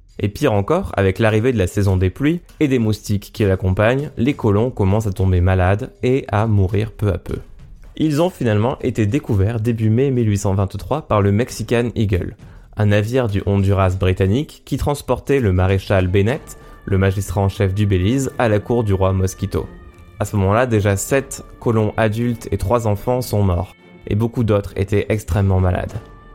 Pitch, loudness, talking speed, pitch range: 105 Hz, -18 LUFS, 180 wpm, 95-120 Hz